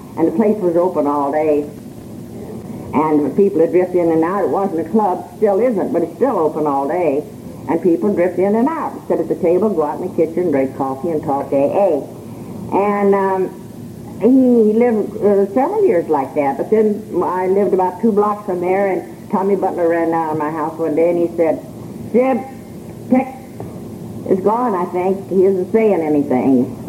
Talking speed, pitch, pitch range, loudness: 195 wpm, 180 Hz, 155-205 Hz, -16 LUFS